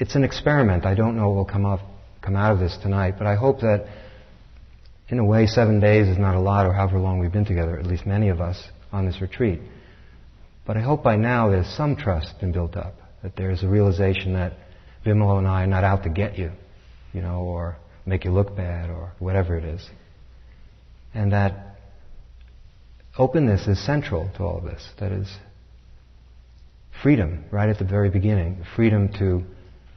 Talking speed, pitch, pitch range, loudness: 195 wpm, 95 Hz, 85-105 Hz, -22 LUFS